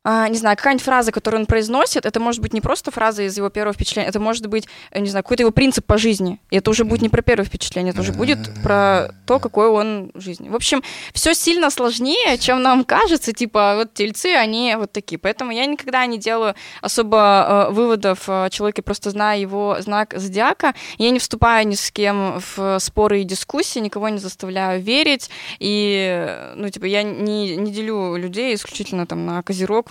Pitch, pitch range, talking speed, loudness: 210 Hz, 195-235 Hz, 195 wpm, -18 LUFS